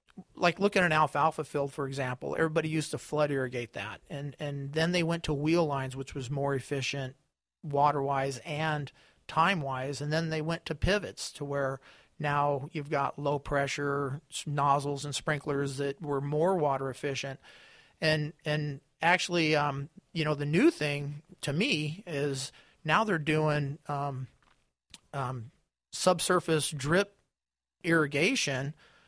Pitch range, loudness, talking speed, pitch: 140-160 Hz, -30 LUFS, 140 wpm, 145 Hz